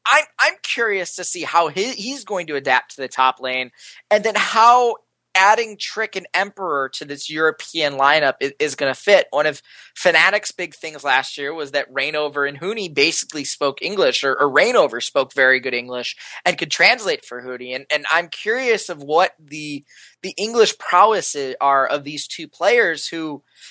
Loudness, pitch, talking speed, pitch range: -18 LUFS, 155 Hz, 185 wpm, 140-205 Hz